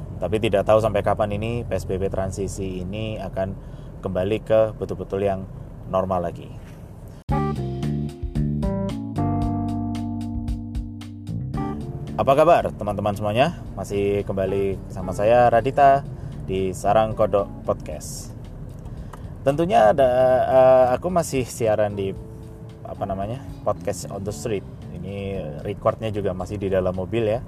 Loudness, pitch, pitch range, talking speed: -22 LUFS, 100 Hz, 95-110 Hz, 110 wpm